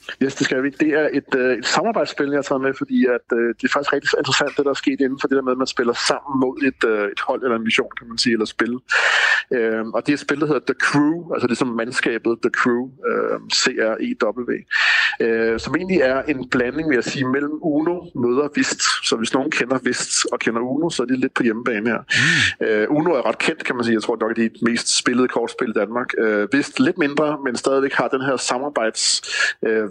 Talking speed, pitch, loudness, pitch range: 250 wpm, 135 Hz, -19 LUFS, 120-145 Hz